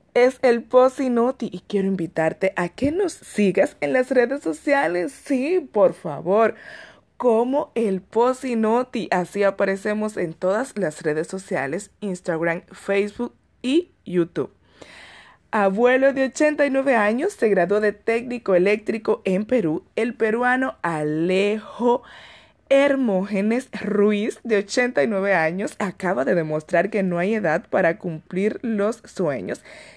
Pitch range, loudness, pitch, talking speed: 185-245 Hz, -22 LUFS, 210 Hz, 120 wpm